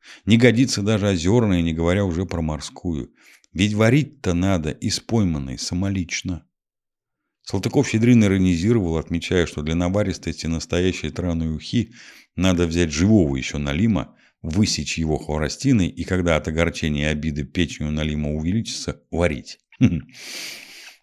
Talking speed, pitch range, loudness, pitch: 125 wpm, 80-100 Hz, -21 LUFS, 85 Hz